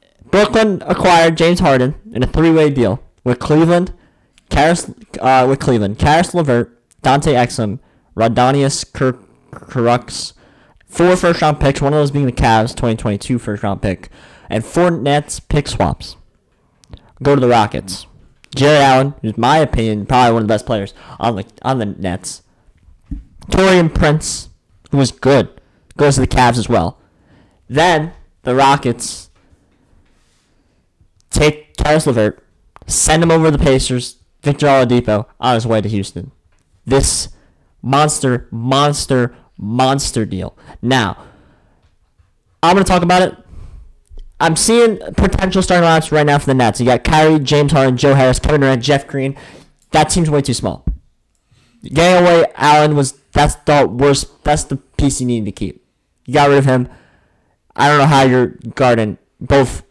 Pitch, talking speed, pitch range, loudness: 130 Hz, 150 wpm, 110-150 Hz, -14 LUFS